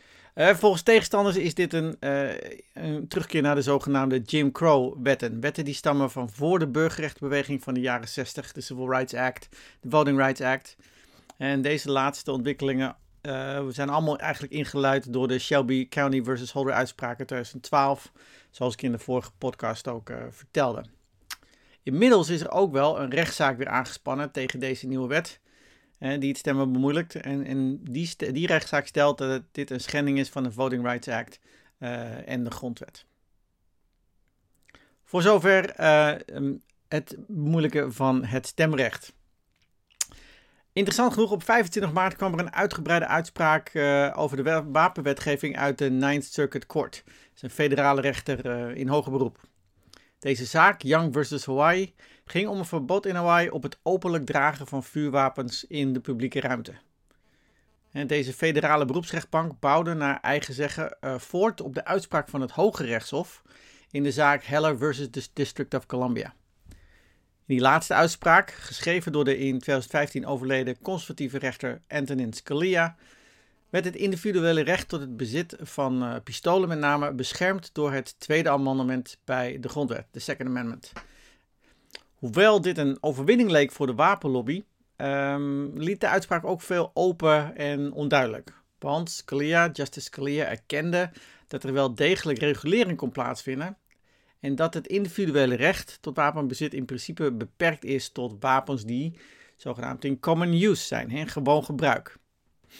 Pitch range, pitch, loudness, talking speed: 130-160 Hz, 140 Hz, -26 LUFS, 155 wpm